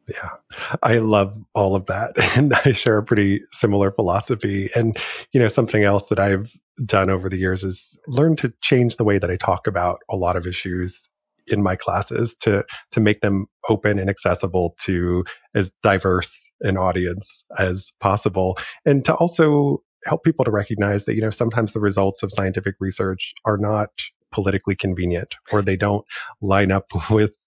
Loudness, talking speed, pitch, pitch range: -20 LUFS, 175 wpm, 100 Hz, 95-110 Hz